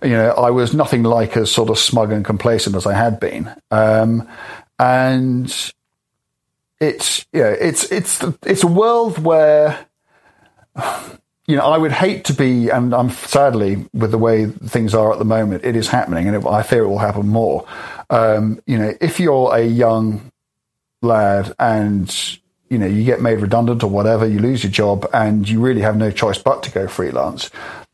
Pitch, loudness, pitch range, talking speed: 115 Hz, -16 LUFS, 110-130 Hz, 185 wpm